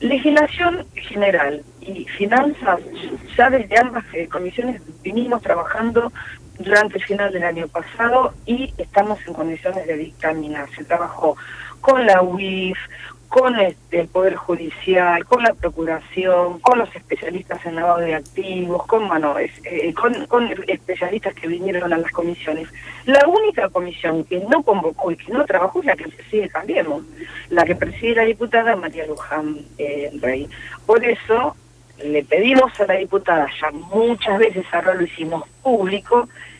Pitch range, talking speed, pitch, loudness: 165-235 Hz, 150 wpm, 185 Hz, -19 LUFS